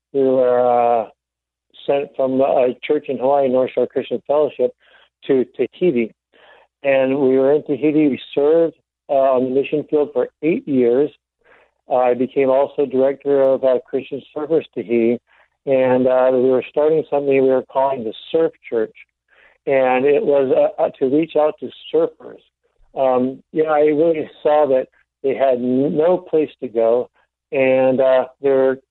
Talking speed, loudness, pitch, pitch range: 165 wpm, -18 LUFS, 135 Hz, 130-150 Hz